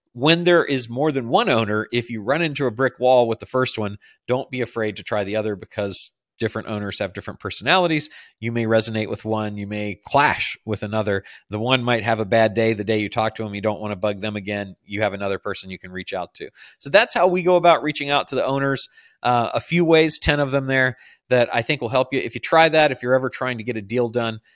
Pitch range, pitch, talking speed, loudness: 105-135 Hz, 115 Hz, 265 wpm, -21 LUFS